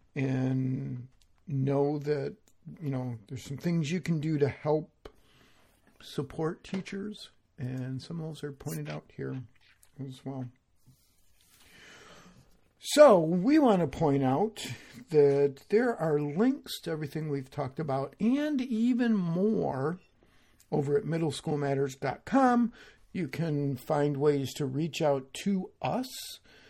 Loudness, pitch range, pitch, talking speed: -30 LUFS, 130-175 Hz, 145 Hz, 125 wpm